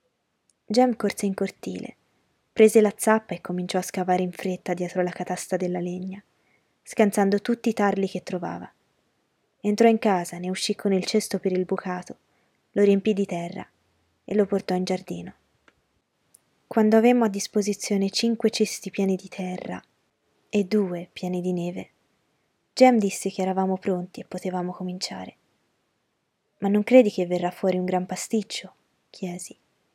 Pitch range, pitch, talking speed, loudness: 180-210 Hz, 190 Hz, 150 wpm, -24 LUFS